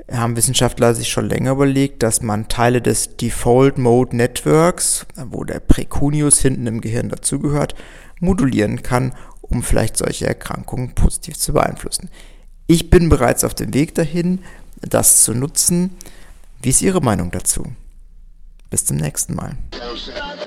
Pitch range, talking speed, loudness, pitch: 110-140 Hz, 135 wpm, -17 LUFS, 125 Hz